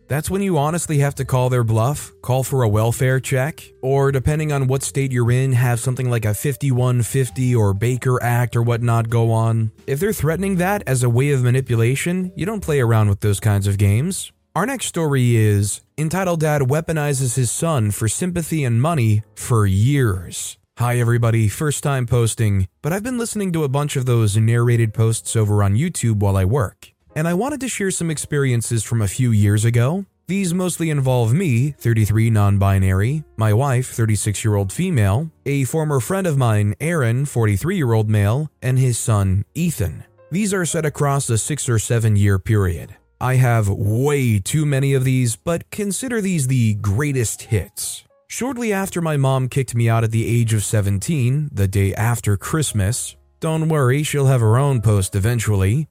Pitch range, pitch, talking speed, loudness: 110-150 Hz, 125 Hz, 185 wpm, -19 LUFS